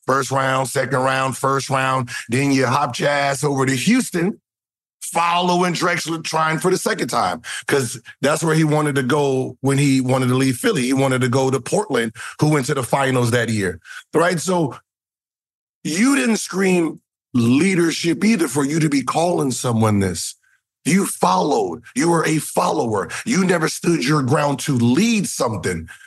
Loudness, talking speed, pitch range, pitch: -19 LUFS, 170 wpm, 130-170 Hz, 145 Hz